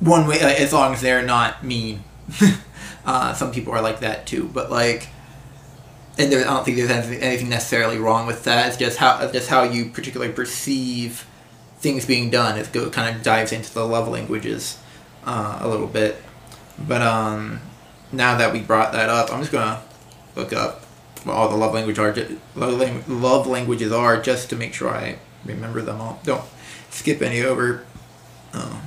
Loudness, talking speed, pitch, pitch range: -20 LUFS, 180 wpm, 120 Hz, 115-130 Hz